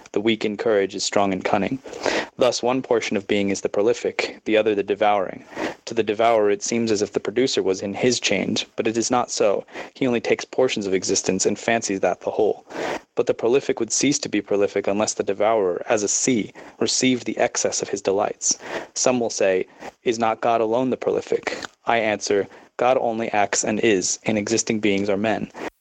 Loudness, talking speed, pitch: -22 LUFS, 210 wpm, 115 Hz